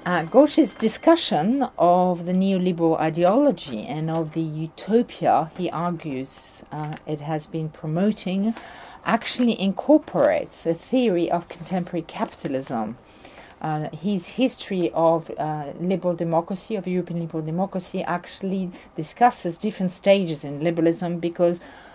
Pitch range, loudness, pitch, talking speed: 160-195 Hz, -23 LUFS, 175 Hz, 120 wpm